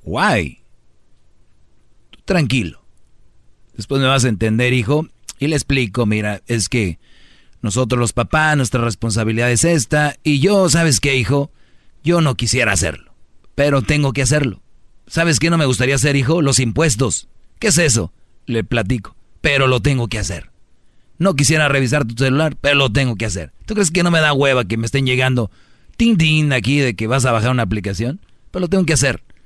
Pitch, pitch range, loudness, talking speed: 130 Hz, 115-150 Hz, -16 LUFS, 185 wpm